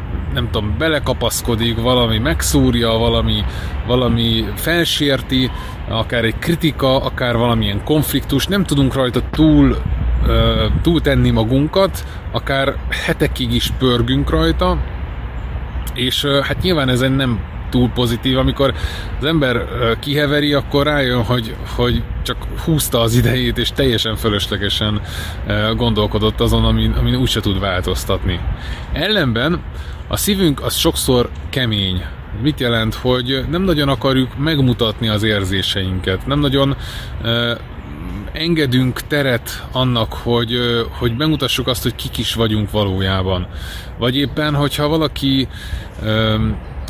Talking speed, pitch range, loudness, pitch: 120 wpm, 105-135 Hz, -17 LUFS, 120 Hz